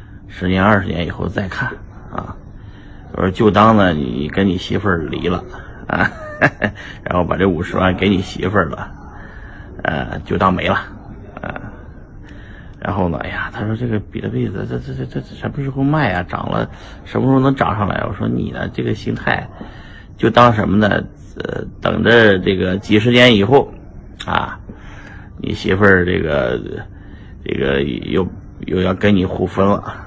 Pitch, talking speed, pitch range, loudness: 100 Hz, 235 characters per minute, 95-105 Hz, -16 LUFS